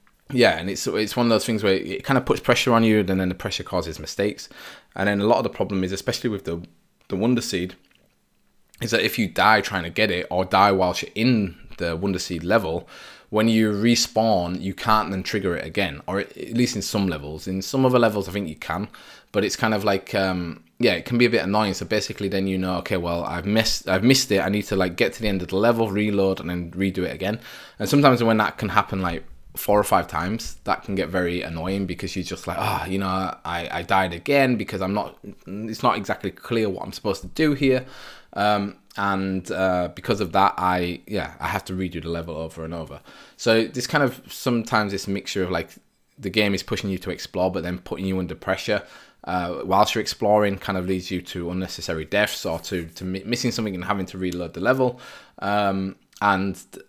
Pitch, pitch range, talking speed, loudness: 95 Hz, 90-110 Hz, 240 wpm, -23 LUFS